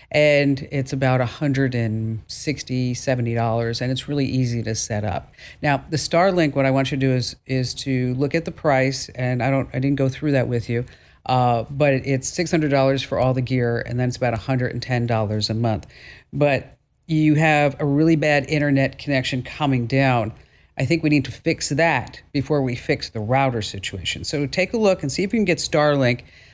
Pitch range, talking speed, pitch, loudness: 120-145 Hz, 195 wpm, 135 Hz, -21 LUFS